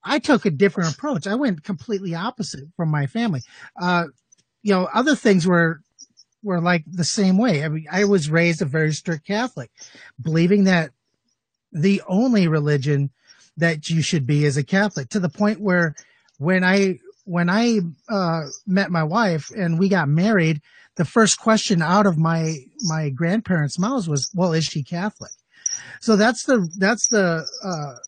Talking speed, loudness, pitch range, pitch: 170 wpm, -20 LUFS, 160-205 Hz, 180 Hz